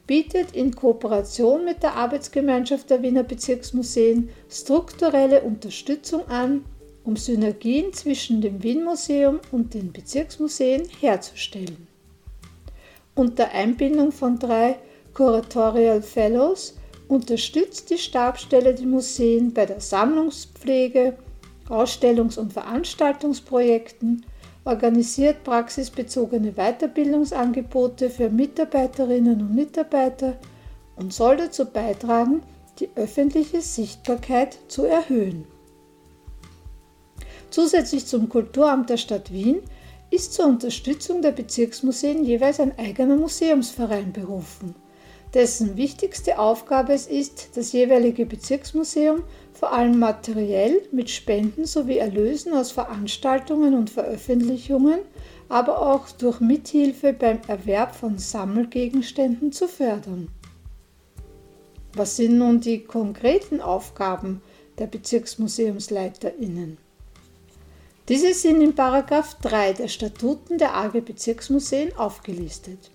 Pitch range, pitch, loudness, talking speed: 215-280 Hz, 245 Hz, -22 LUFS, 95 wpm